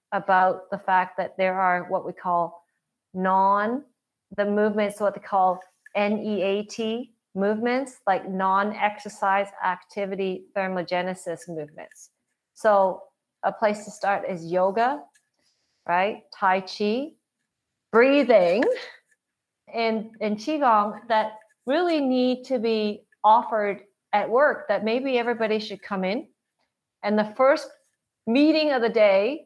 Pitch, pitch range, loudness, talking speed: 210 Hz, 190-230 Hz, -24 LUFS, 115 wpm